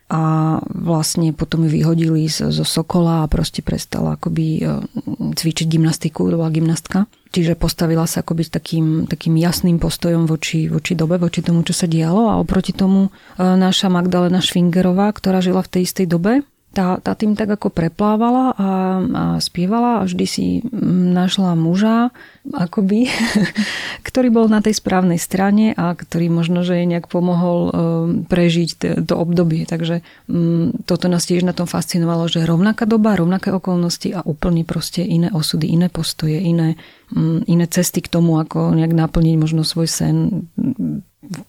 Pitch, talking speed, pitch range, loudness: 175 Hz, 160 wpm, 165-190 Hz, -17 LUFS